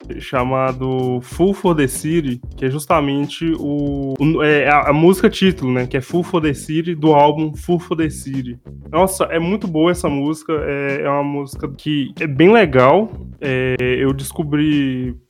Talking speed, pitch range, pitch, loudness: 175 wpm, 135-165 Hz, 145 Hz, -17 LUFS